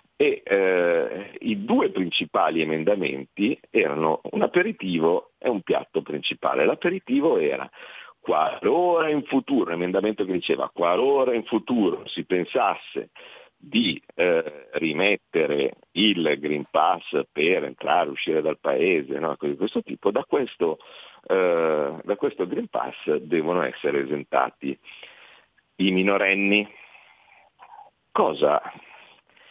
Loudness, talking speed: -24 LUFS, 115 wpm